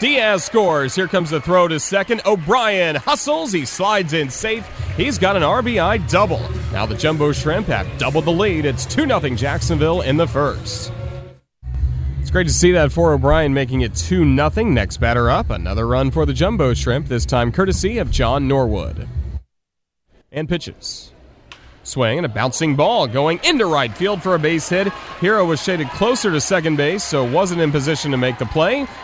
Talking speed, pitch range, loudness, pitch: 185 wpm, 120-175 Hz, -18 LUFS, 150 Hz